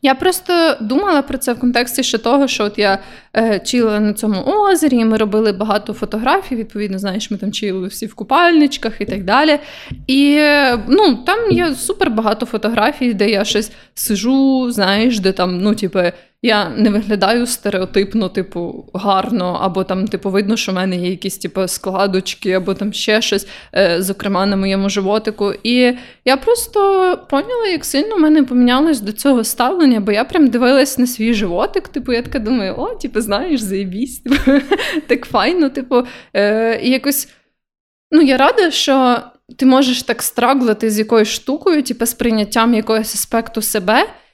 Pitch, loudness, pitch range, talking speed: 230 Hz, -15 LUFS, 205-275 Hz, 170 wpm